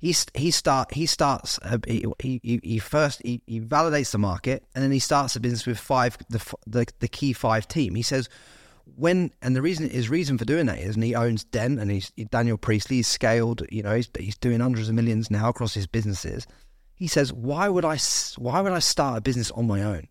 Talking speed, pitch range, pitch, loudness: 225 wpm, 110-140 Hz, 120 Hz, -25 LUFS